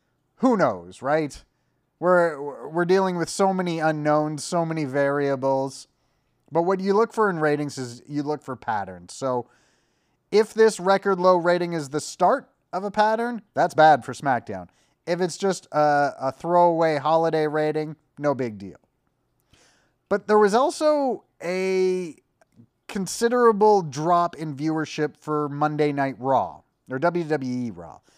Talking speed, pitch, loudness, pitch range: 145 wpm, 155 Hz, -23 LUFS, 145-185 Hz